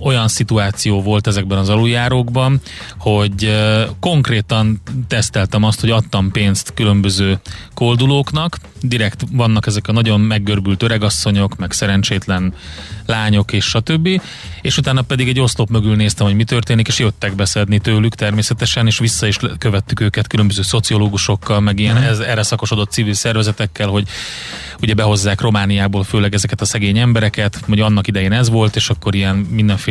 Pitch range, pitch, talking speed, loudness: 100-115 Hz, 110 Hz, 150 wpm, -15 LUFS